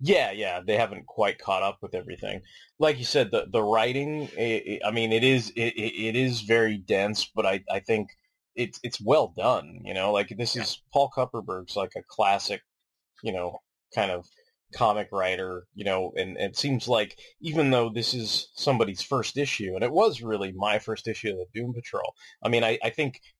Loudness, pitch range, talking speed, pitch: -27 LUFS, 100-125 Hz, 205 wpm, 115 Hz